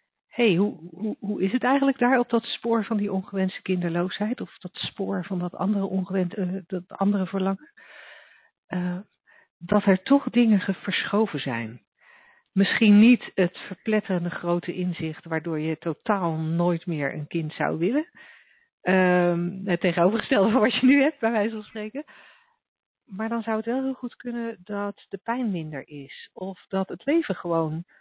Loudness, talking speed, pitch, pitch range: -25 LUFS, 170 wpm, 195 Hz, 175-225 Hz